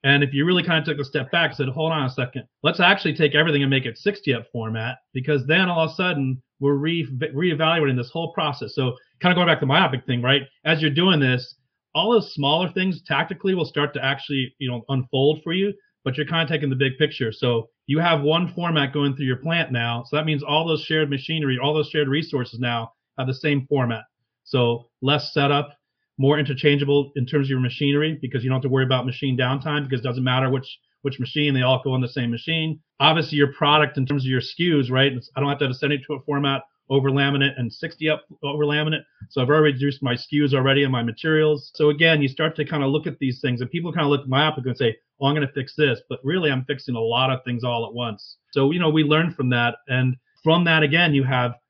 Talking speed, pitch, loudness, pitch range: 255 wpm, 140 Hz, -21 LUFS, 130-155 Hz